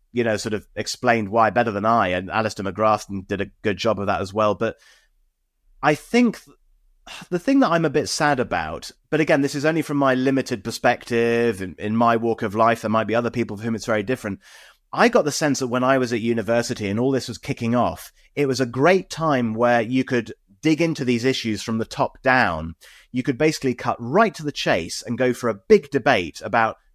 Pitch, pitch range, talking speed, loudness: 120 Hz, 110-135 Hz, 230 wpm, -21 LUFS